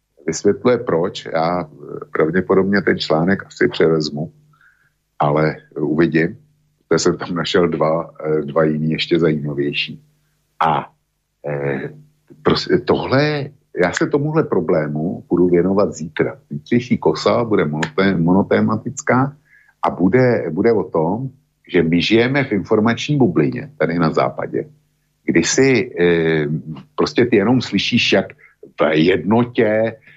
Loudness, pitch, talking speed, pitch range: -17 LUFS, 100 Hz, 115 wpm, 80-135 Hz